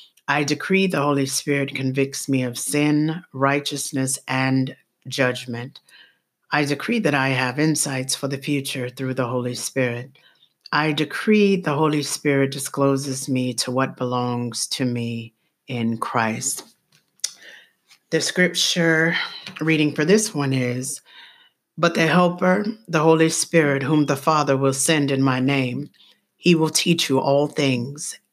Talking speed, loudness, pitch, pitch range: 140 wpm, -21 LUFS, 140 Hz, 130-155 Hz